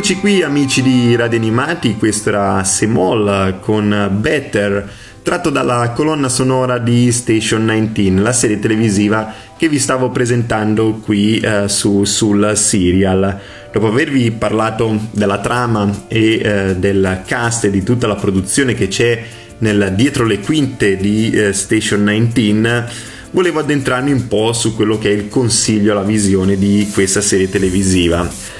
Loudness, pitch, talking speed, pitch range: -14 LUFS, 110 Hz, 145 wpm, 100-120 Hz